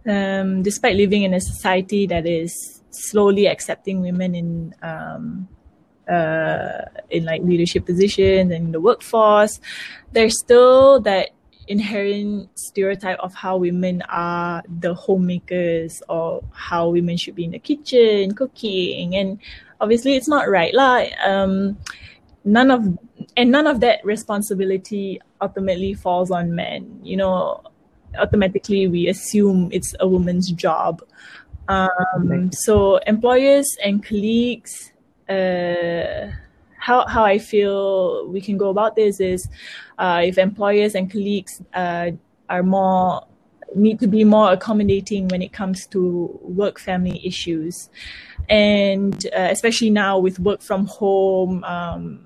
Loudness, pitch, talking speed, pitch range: -18 LUFS, 195 Hz, 130 wpm, 180-210 Hz